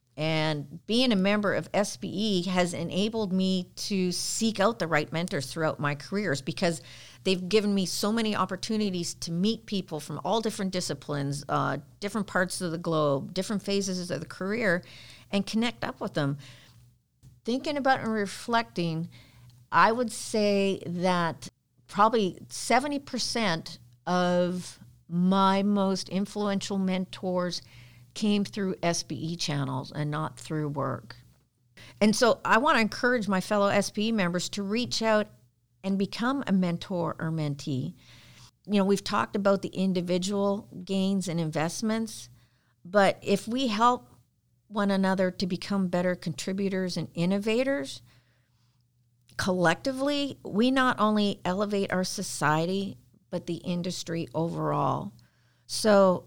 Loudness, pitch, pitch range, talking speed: -28 LUFS, 180 Hz, 150-205 Hz, 130 wpm